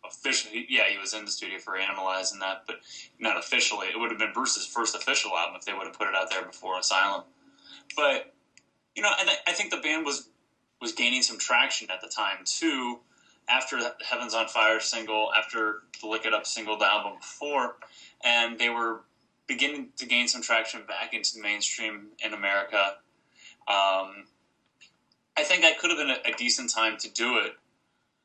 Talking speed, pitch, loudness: 195 wpm, 115 Hz, -26 LUFS